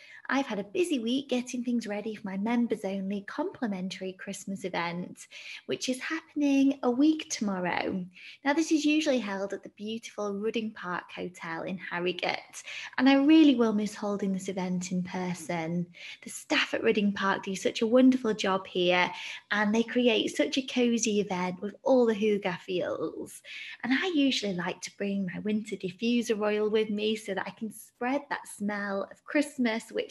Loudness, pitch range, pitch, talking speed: -29 LUFS, 195-255 Hz, 215 Hz, 175 wpm